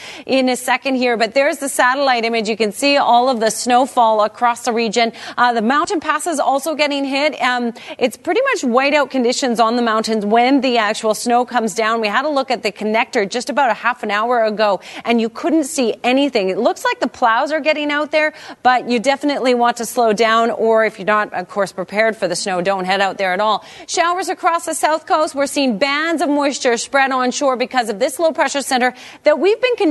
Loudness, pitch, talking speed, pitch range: -16 LUFS, 250 Hz, 230 wpm, 225-290 Hz